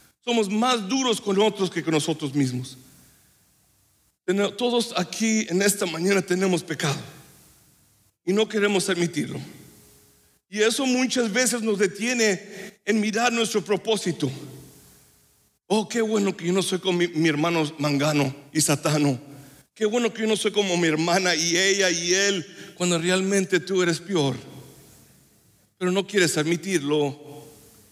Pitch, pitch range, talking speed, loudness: 185 Hz, 155-210 Hz, 140 wpm, -23 LUFS